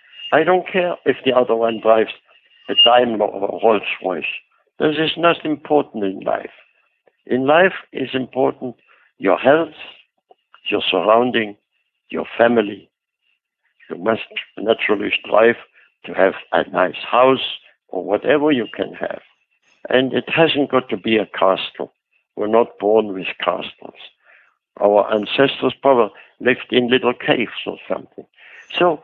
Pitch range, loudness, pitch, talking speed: 110-135 Hz, -18 LUFS, 120 Hz, 140 wpm